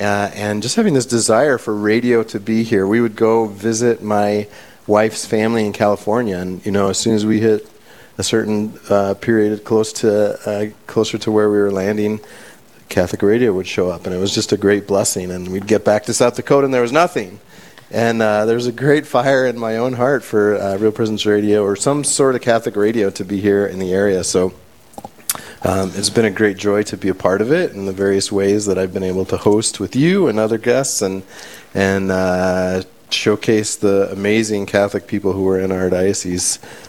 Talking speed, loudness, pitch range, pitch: 220 wpm, -17 LUFS, 100-115 Hz, 105 Hz